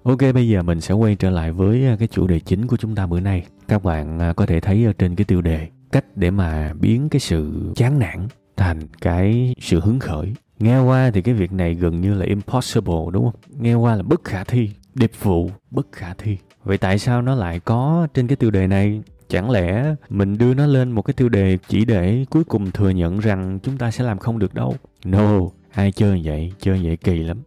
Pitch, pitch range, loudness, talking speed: 100 Hz, 90-120 Hz, -19 LUFS, 230 wpm